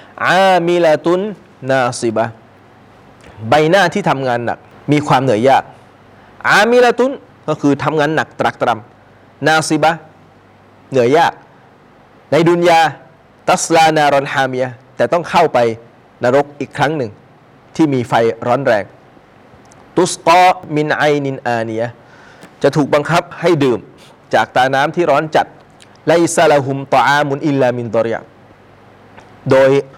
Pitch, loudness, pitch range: 140 Hz, -14 LUFS, 120-160 Hz